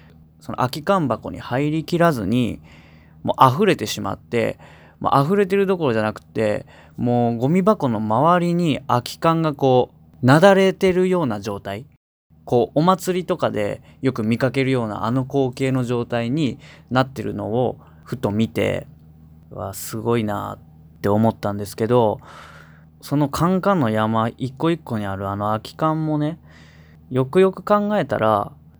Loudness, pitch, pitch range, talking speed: -20 LUFS, 120 Hz, 100-155 Hz, 290 characters per minute